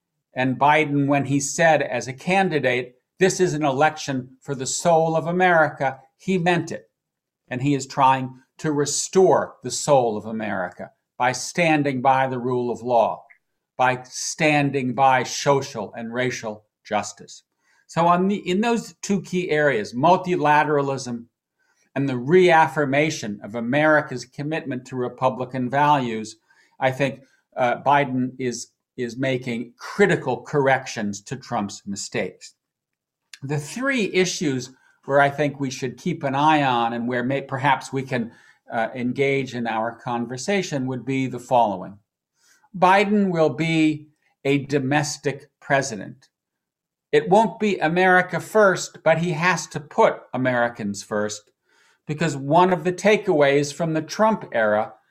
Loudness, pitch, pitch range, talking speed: -21 LUFS, 140 Hz, 125-160 Hz, 140 wpm